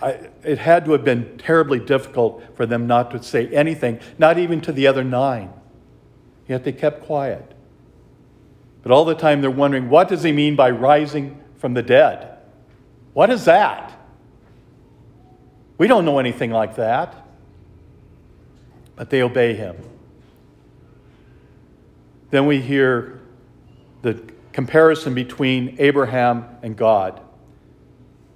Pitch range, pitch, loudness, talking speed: 120-145 Hz, 130 Hz, -18 LUFS, 130 wpm